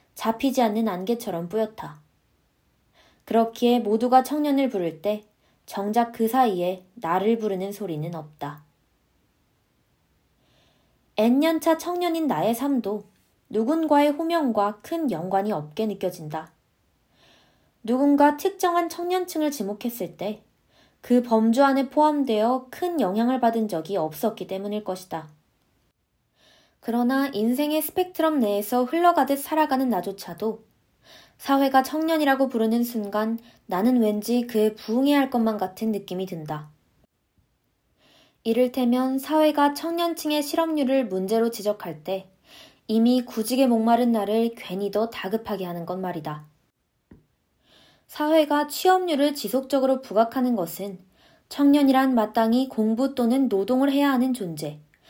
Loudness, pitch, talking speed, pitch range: -23 LUFS, 230 Hz, 270 characters per minute, 205-275 Hz